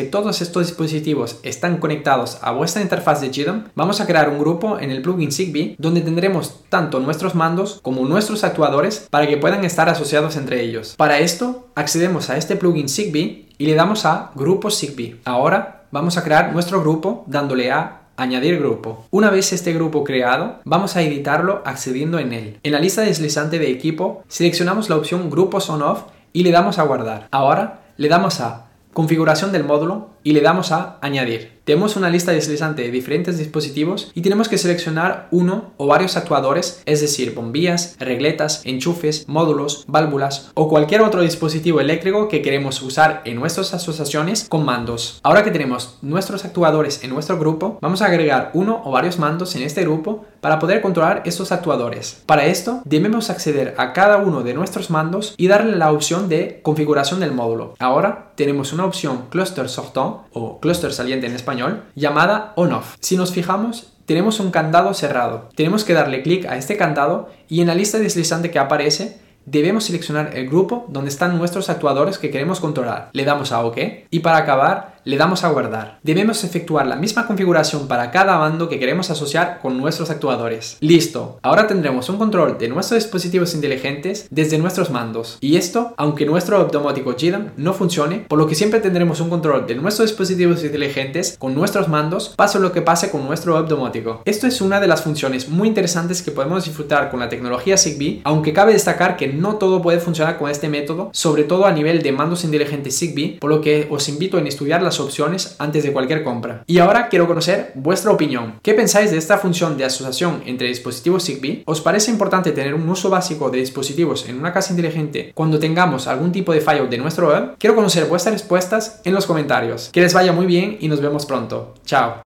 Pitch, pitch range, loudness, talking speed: 160 Hz, 145-185 Hz, -18 LUFS, 190 wpm